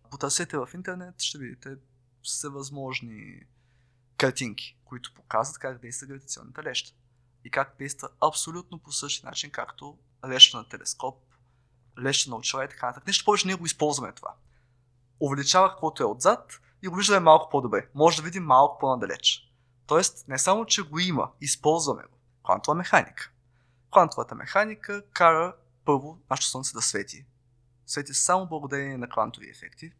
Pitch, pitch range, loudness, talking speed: 135 Hz, 125-160 Hz, -25 LUFS, 150 wpm